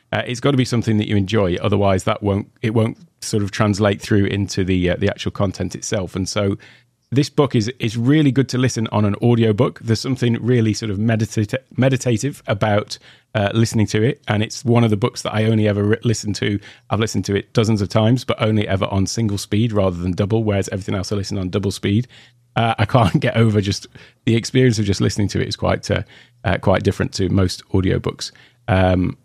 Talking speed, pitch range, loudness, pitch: 230 wpm, 100-120 Hz, -19 LUFS, 110 Hz